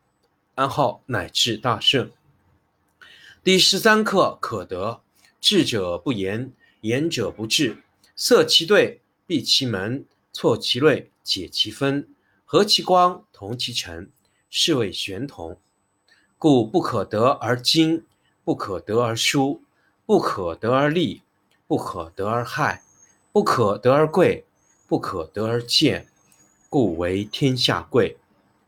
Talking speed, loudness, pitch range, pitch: 165 characters per minute, -21 LUFS, 100-155 Hz, 120 Hz